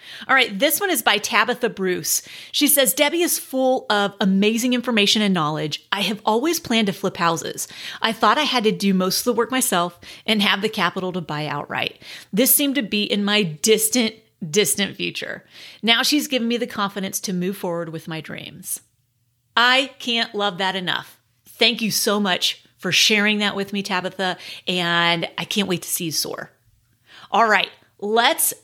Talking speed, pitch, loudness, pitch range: 190 wpm, 205 Hz, -20 LUFS, 180-240 Hz